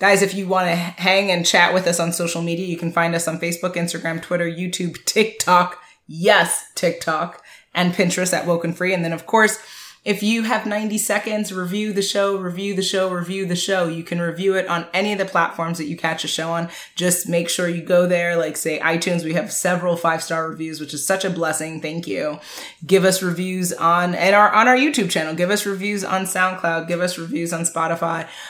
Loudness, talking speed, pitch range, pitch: -20 LUFS, 220 wpm, 170-190 Hz, 175 Hz